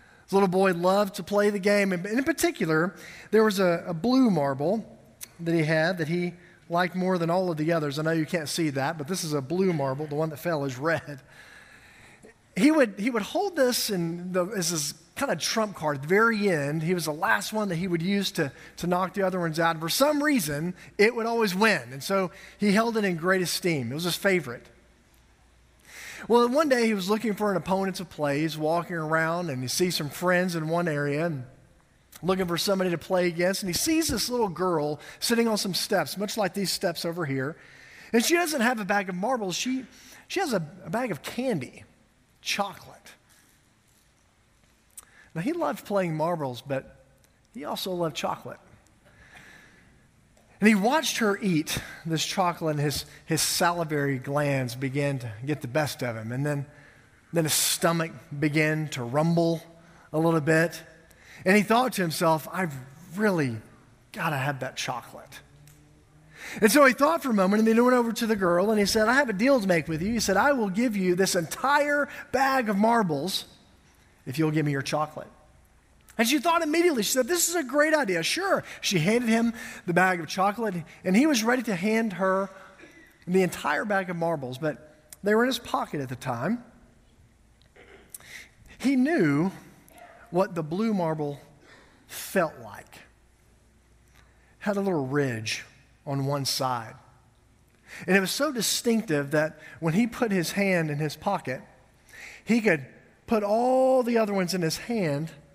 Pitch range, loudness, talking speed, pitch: 155-215 Hz, -26 LUFS, 190 wpm, 180 Hz